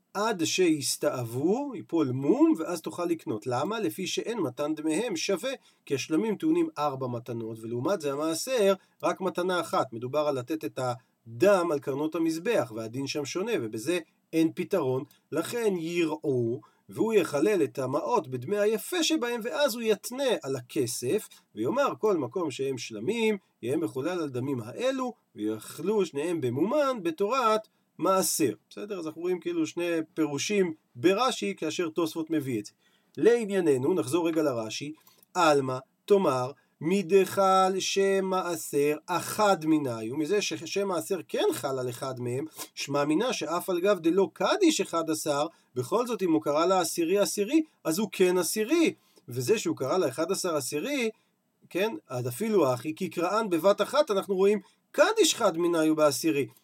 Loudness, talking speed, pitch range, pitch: -28 LUFS, 150 wpm, 150-200 Hz, 170 Hz